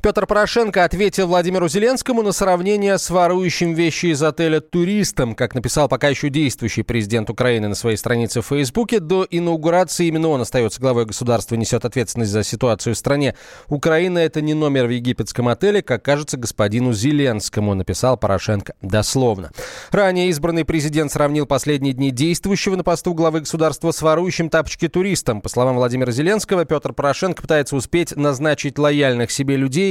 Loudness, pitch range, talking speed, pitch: -18 LUFS, 125-175 Hz, 160 wpm, 145 Hz